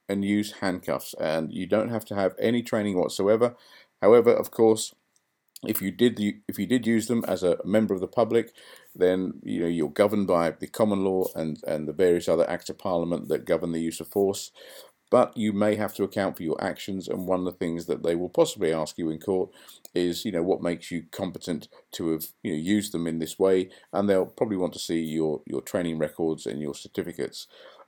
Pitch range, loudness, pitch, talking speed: 85-105 Hz, -26 LUFS, 95 Hz, 225 wpm